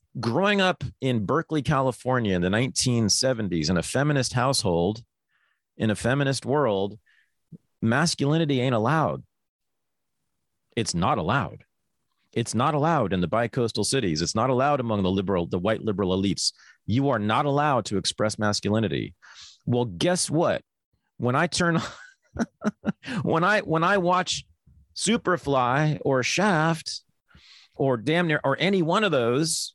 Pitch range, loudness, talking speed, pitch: 110-160 Hz, -24 LUFS, 140 wpm, 130 Hz